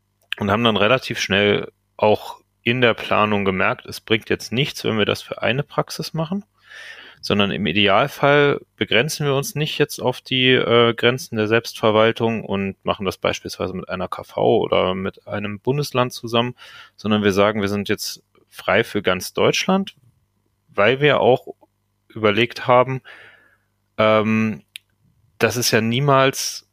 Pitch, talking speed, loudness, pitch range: 115 Hz, 150 wpm, -19 LUFS, 105-125 Hz